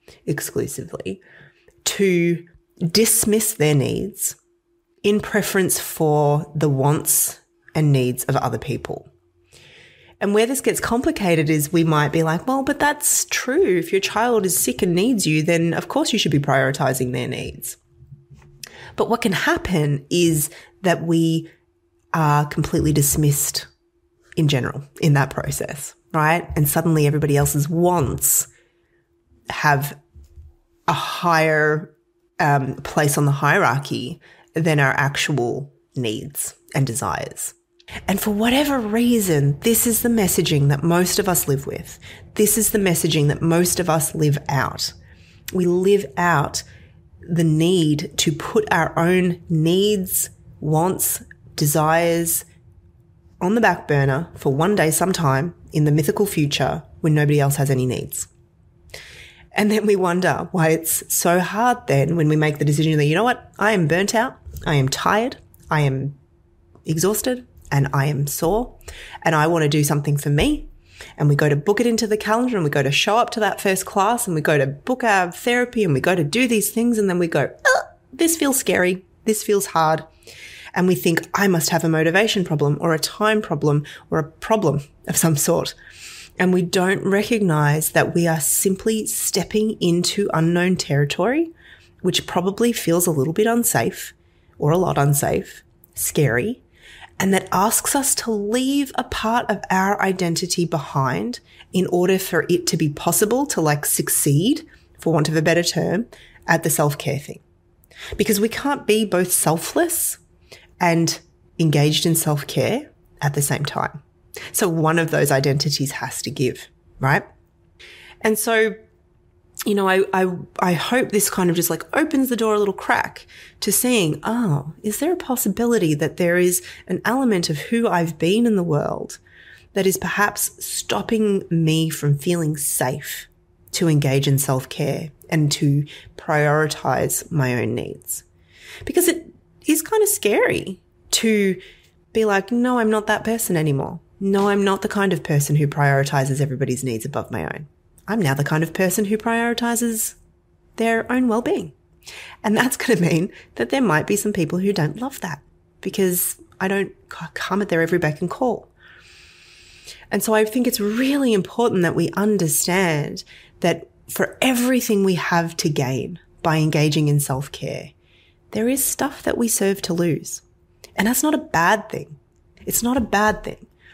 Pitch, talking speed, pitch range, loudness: 170 Hz, 165 wpm, 150-210 Hz, -20 LUFS